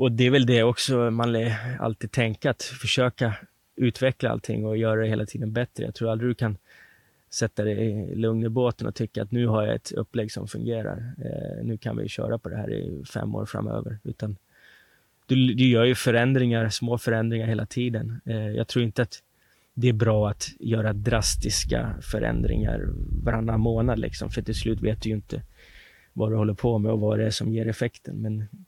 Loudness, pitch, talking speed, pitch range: -26 LUFS, 115 Hz, 205 wpm, 110-120 Hz